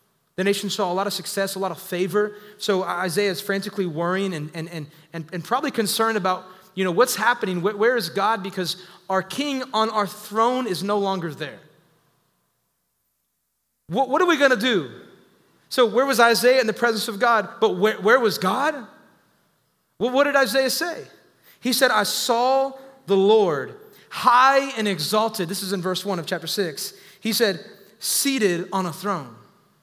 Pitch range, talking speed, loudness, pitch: 185-240 Hz, 180 wpm, -22 LUFS, 205 Hz